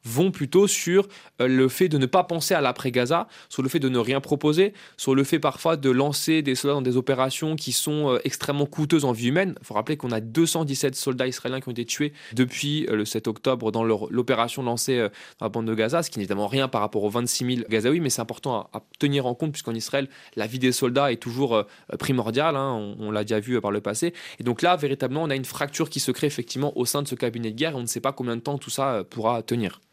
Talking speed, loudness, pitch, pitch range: 260 wpm, -24 LUFS, 130 Hz, 120-150 Hz